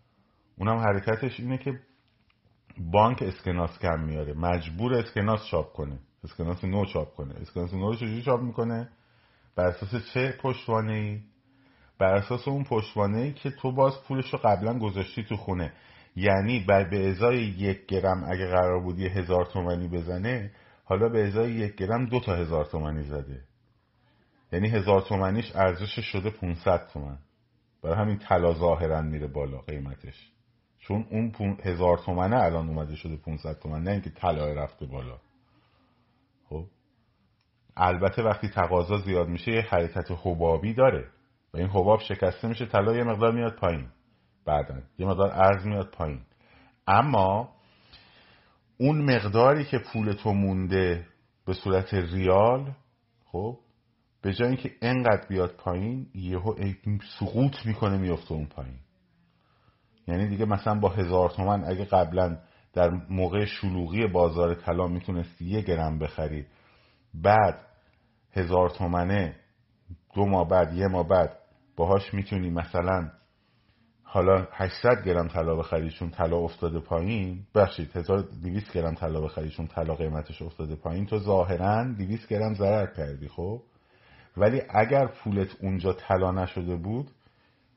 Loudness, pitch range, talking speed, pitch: -27 LUFS, 85-110 Hz, 135 wpm, 95 Hz